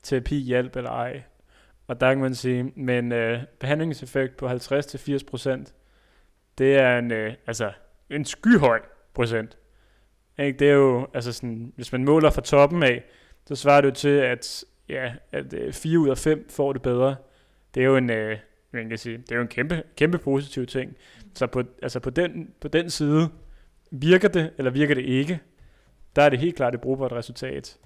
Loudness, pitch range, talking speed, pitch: -23 LUFS, 120-145 Hz, 195 wpm, 130 Hz